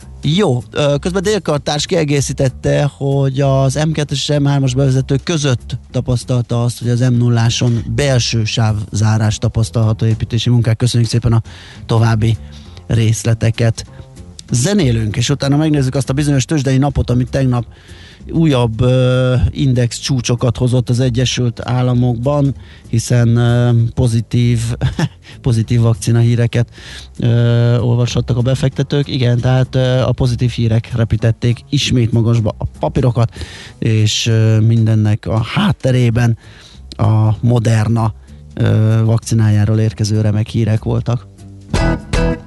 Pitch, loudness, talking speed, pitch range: 120 Hz, -15 LUFS, 105 wpm, 110-130 Hz